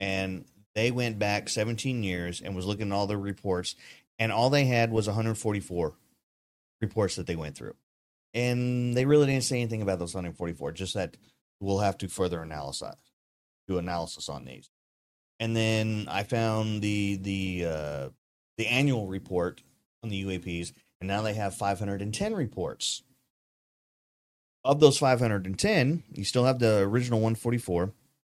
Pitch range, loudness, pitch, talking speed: 90-115 Hz, -29 LUFS, 100 Hz, 150 wpm